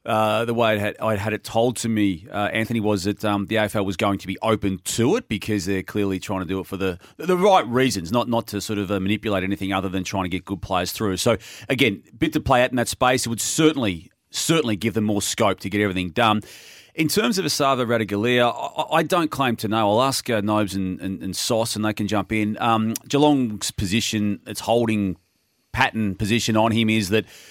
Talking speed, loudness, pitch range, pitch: 230 wpm, -22 LUFS, 100-120 Hz, 110 Hz